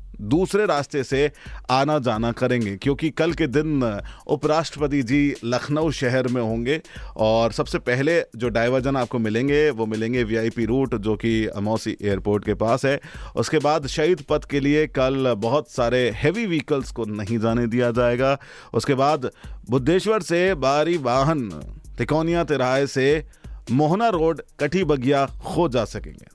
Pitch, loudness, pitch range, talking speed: 135 Hz, -22 LUFS, 115-150 Hz, 150 wpm